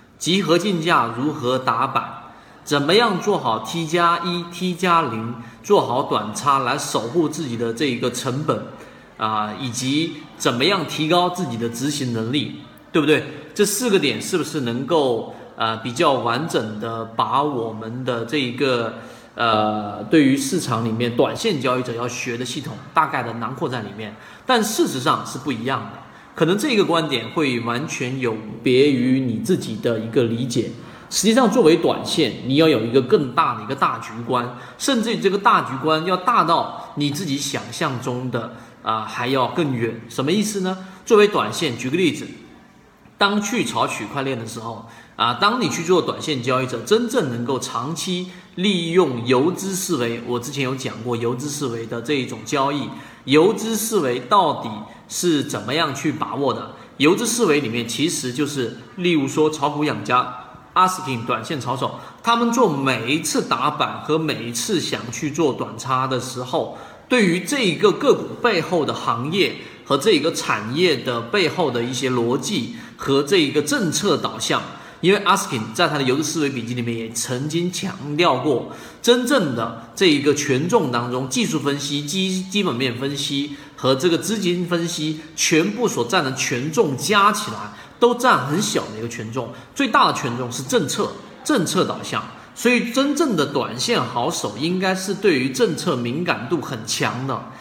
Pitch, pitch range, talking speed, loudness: 140 Hz, 120-175 Hz, 260 characters per minute, -20 LUFS